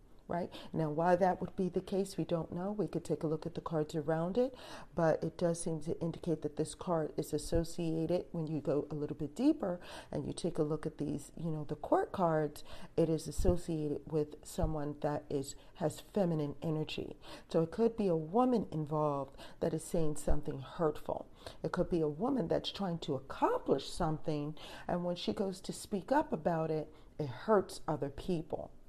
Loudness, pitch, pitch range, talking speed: -36 LUFS, 160 Hz, 150-180 Hz, 200 wpm